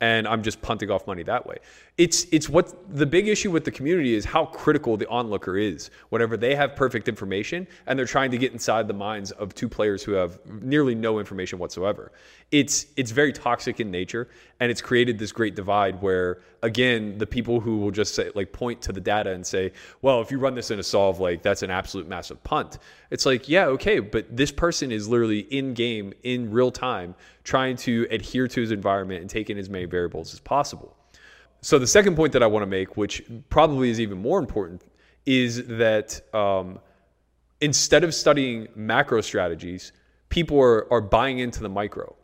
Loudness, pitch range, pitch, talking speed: -24 LUFS, 100-130 Hz, 115 Hz, 205 wpm